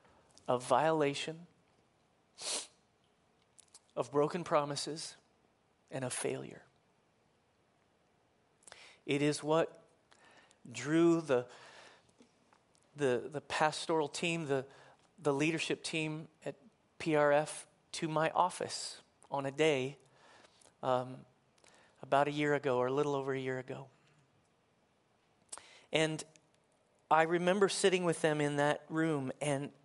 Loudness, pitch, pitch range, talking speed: -34 LUFS, 145 Hz, 135-160 Hz, 105 wpm